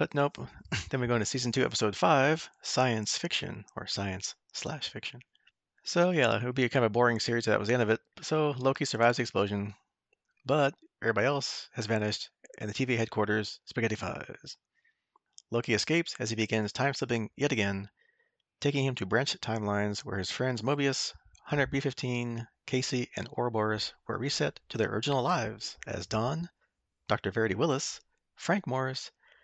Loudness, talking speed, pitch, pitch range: -31 LUFS, 170 wpm, 120 Hz, 110-135 Hz